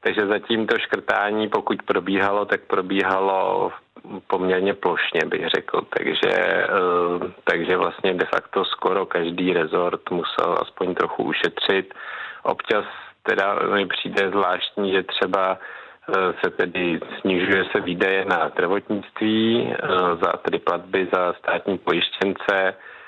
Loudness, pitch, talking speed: -22 LUFS, 105 Hz, 115 wpm